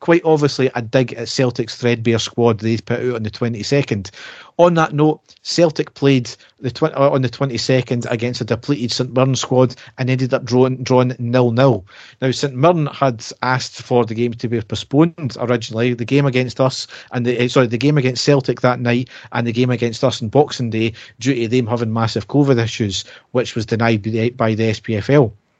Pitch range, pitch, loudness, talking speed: 115-135 Hz, 125 Hz, -17 LUFS, 200 wpm